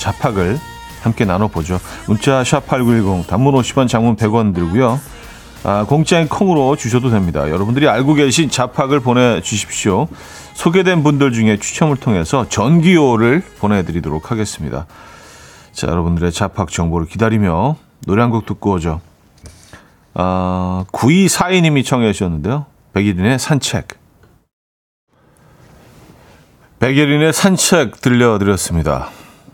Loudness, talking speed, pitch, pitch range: -15 LUFS, 270 characters per minute, 115 Hz, 90-140 Hz